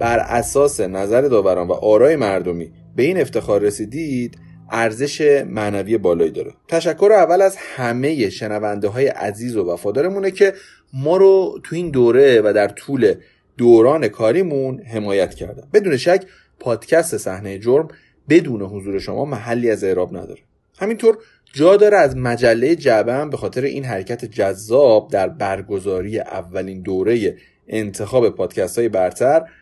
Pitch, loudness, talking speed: 125 Hz, -17 LUFS, 140 wpm